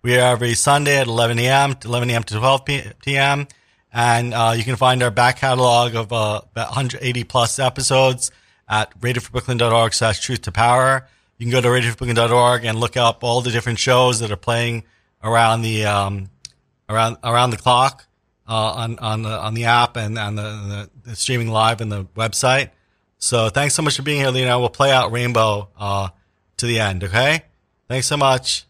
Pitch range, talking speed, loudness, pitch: 110-125 Hz, 190 wpm, -18 LUFS, 120 Hz